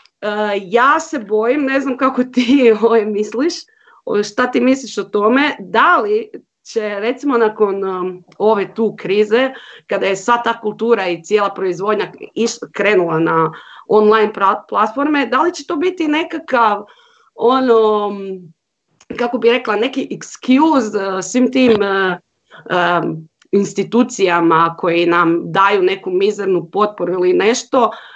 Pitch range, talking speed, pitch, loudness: 195-255 Hz, 120 wpm, 215 Hz, -15 LUFS